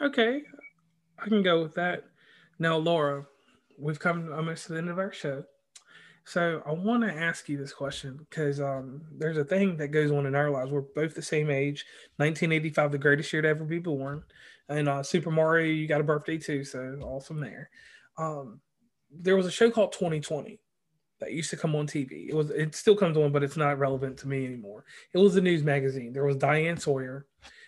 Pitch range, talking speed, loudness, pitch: 140-170 Hz, 210 wpm, -28 LUFS, 155 Hz